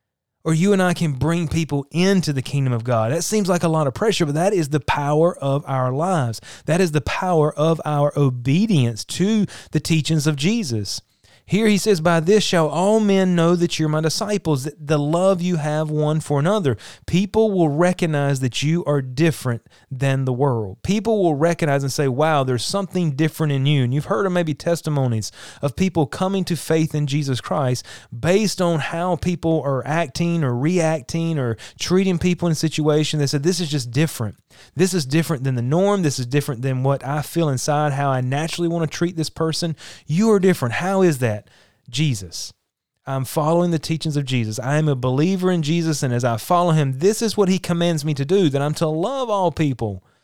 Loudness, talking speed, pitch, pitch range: -20 LUFS, 210 wpm, 155 Hz, 135-175 Hz